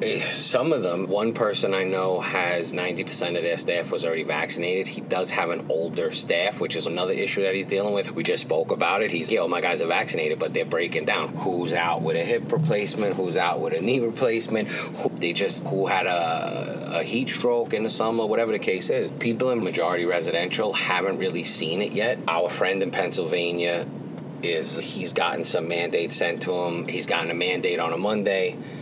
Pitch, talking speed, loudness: 115 Hz, 215 wpm, -25 LUFS